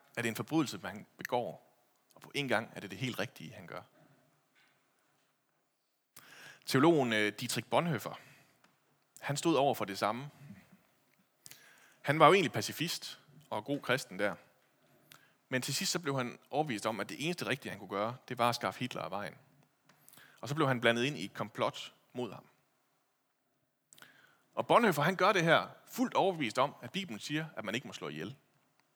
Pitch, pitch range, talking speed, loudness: 125 Hz, 115-150 Hz, 180 wpm, -33 LUFS